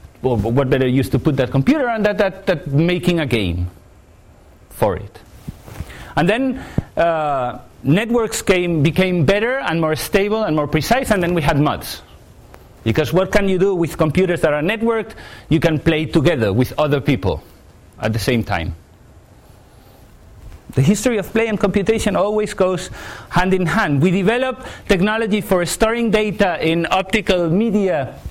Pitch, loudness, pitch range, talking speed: 175 Hz, -17 LUFS, 140-205 Hz, 160 wpm